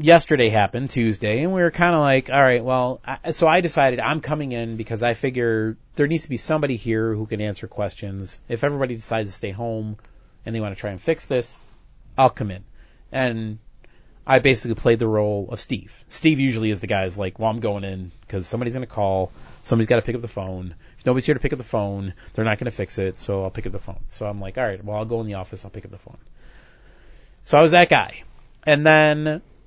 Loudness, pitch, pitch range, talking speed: -21 LUFS, 115 Hz, 105-135 Hz, 250 wpm